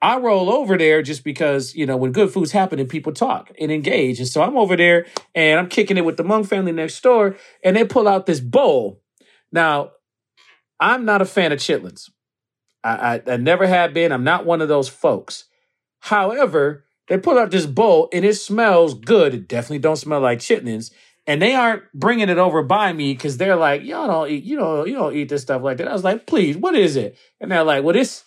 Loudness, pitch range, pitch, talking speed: -18 LUFS, 150-205 Hz, 170 Hz, 225 wpm